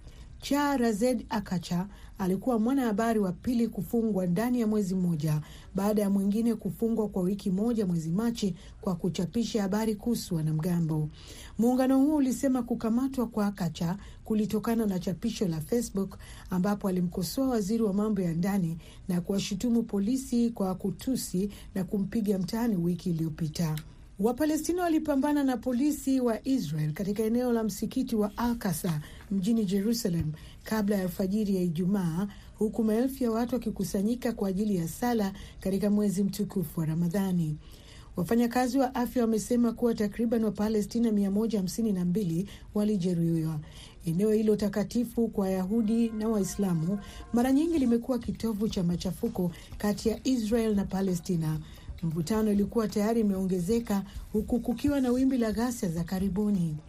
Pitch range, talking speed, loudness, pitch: 190-235 Hz, 130 wpm, -29 LUFS, 210 Hz